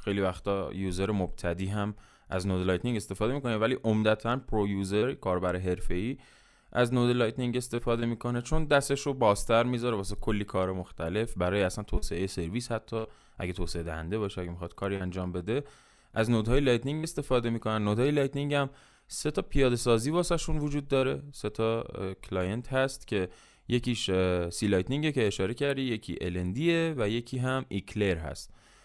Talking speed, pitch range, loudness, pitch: 160 wpm, 95-125 Hz, -30 LUFS, 110 Hz